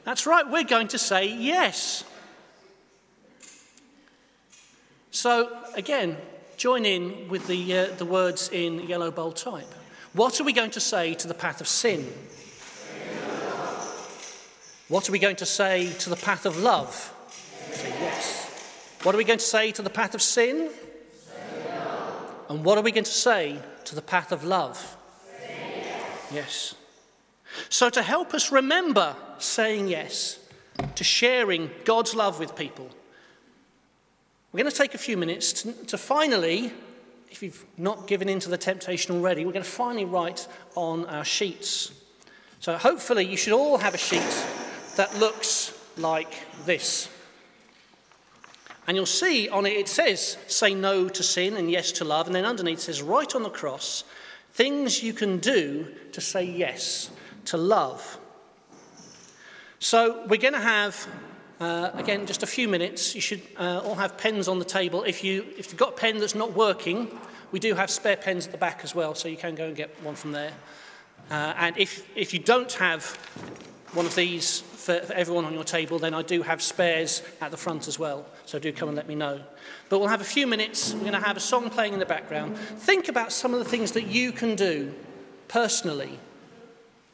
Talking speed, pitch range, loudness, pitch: 180 wpm, 175-230 Hz, -25 LUFS, 195 Hz